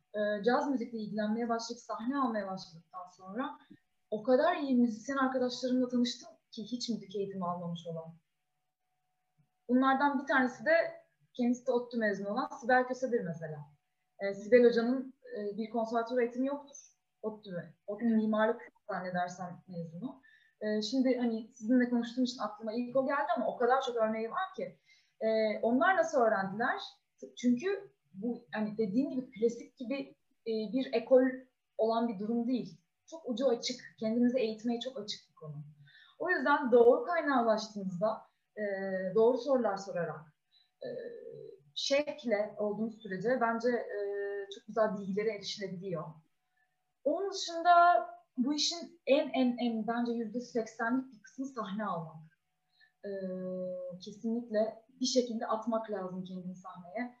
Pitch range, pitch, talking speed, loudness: 200-255 Hz, 230 Hz, 135 wpm, -33 LUFS